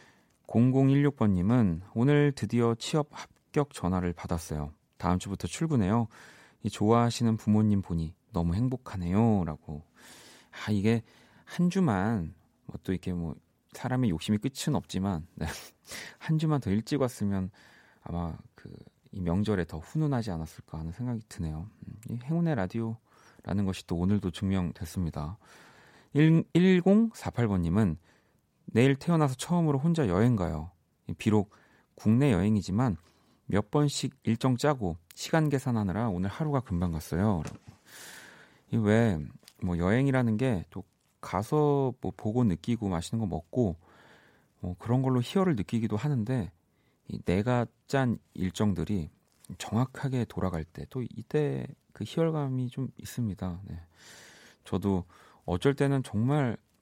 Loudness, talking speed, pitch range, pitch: -29 LUFS, 265 characters per minute, 90-130 Hz, 110 Hz